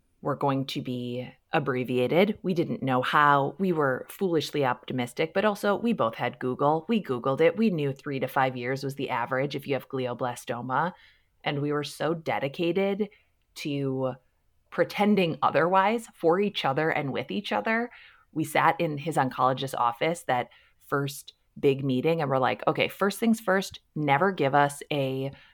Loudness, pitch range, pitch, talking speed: -27 LUFS, 130-170 Hz, 145 Hz, 165 wpm